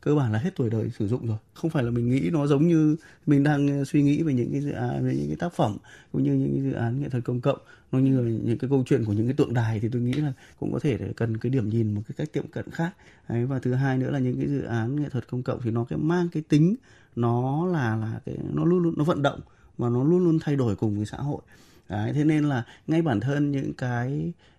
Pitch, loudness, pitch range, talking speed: 130 Hz, -26 LUFS, 115-150 Hz, 295 wpm